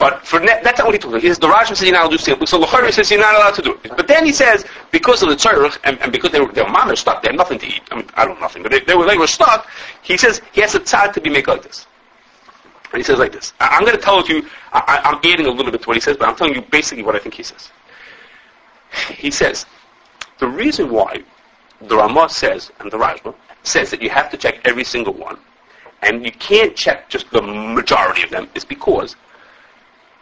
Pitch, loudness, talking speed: 305 Hz, -14 LUFS, 275 wpm